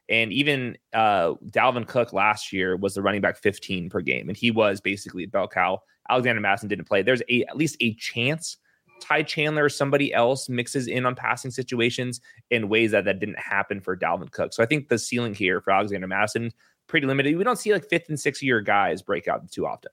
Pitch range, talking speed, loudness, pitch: 105-140 Hz, 215 wpm, -24 LUFS, 120 Hz